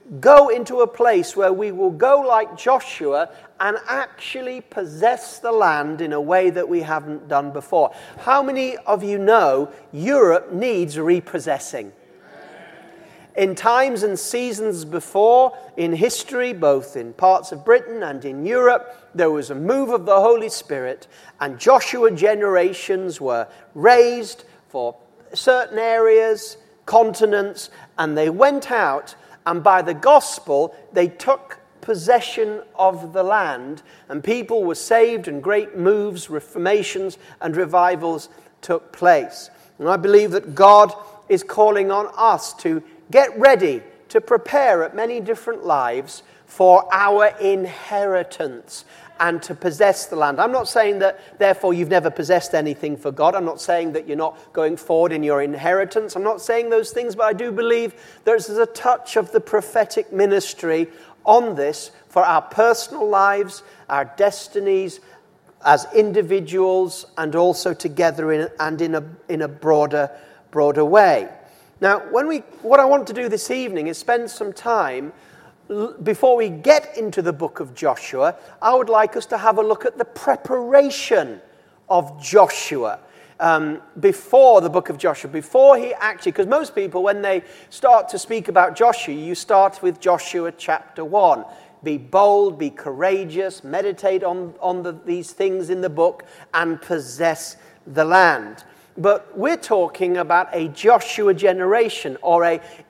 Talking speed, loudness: 150 wpm, -18 LUFS